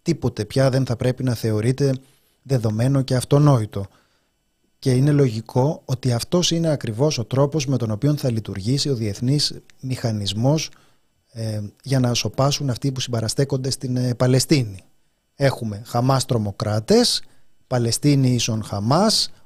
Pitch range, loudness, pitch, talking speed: 115-140 Hz, -21 LUFS, 130 Hz, 135 wpm